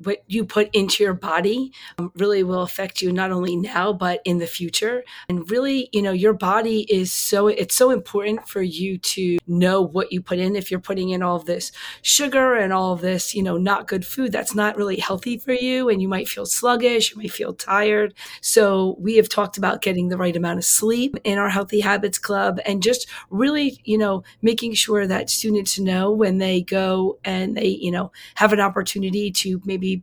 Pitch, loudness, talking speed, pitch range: 200 Hz, -20 LUFS, 215 wpm, 185-215 Hz